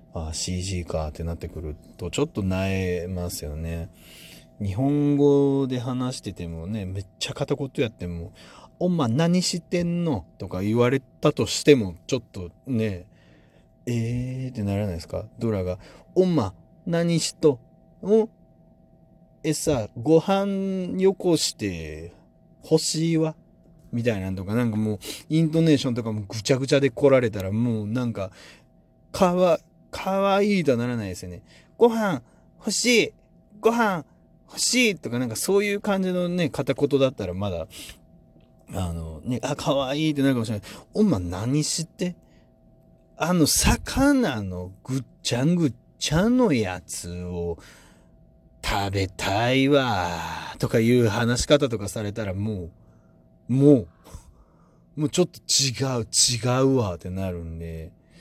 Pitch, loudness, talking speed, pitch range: 120 Hz, -24 LUFS, 275 characters per minute, 95-155 Hz